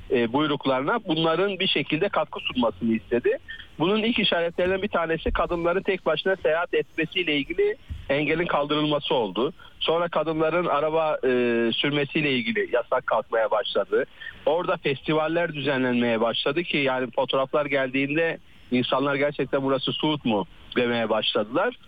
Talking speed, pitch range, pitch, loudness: 125 wpm, 135-175 Hz, 155 Hz, -24 LUFS